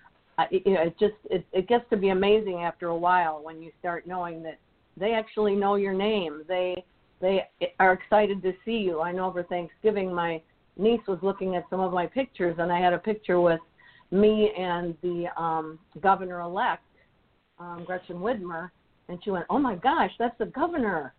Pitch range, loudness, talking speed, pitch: 175-205 Hz, -27 LUFS, 180 wpm, 185 Hz